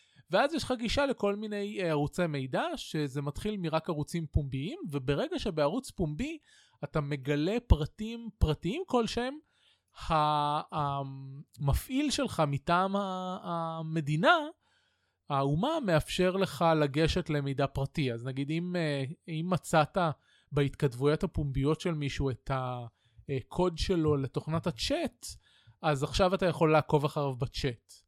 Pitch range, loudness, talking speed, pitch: 145-185 Hz, -31 LUFS, 110 wpm, 155 Hz